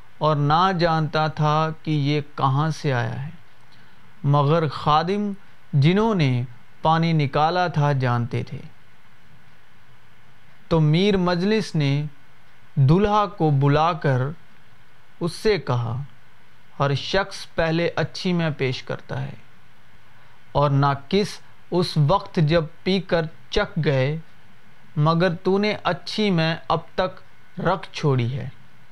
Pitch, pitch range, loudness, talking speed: 150 Hz, 135-170 Hz, -22 LUFS, 120 wpm